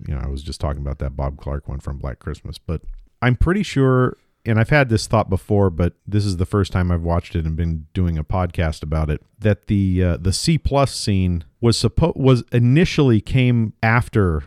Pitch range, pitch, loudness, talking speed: 80-115 Hz, 95 Hz, -20 LUFS, 220 wpm